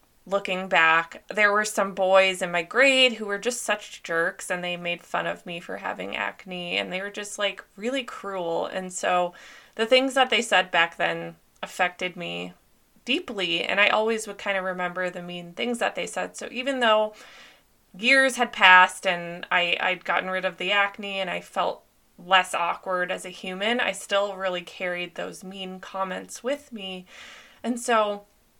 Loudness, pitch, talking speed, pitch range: -24 LUFS, 190 Hz, 185 wpm, 180-215 Hz